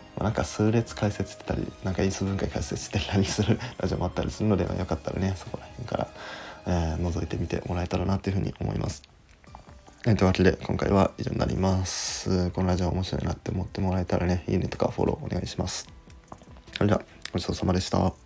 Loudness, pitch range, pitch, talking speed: -28 LUFS, 90-100 Hz, 95 Hz, 445 characters per minute